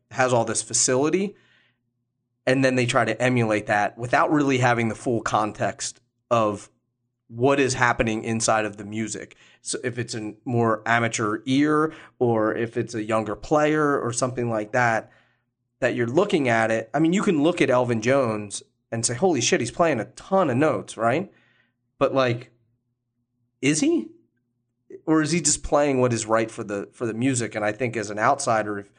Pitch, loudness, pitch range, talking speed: 120 Hz, -23 LUFS, 115-130 Hz, 185 wpm